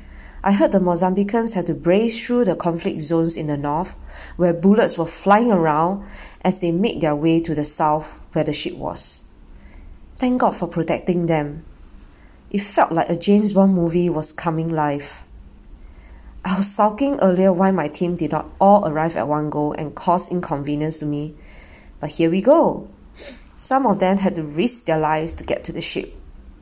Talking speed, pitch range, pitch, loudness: 185 wpm, 150-190 Hz, 165 Hz, -19 LUFS